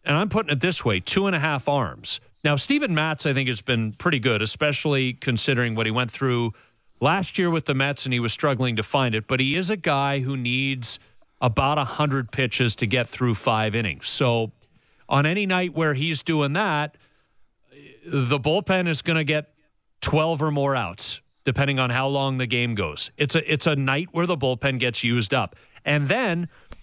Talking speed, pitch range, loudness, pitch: 205 wpm, 125-155 Hz, -23 LUFS, 140 Hz